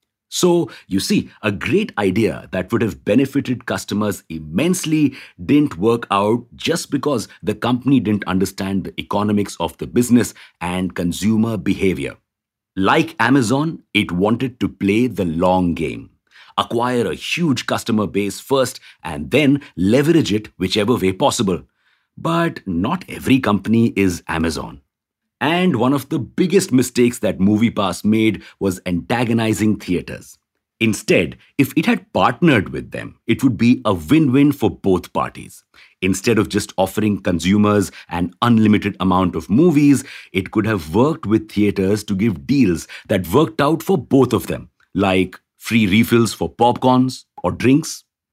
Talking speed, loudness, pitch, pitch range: 145 wpm, -18 LUFS, 110 Hz, 95-130 Hz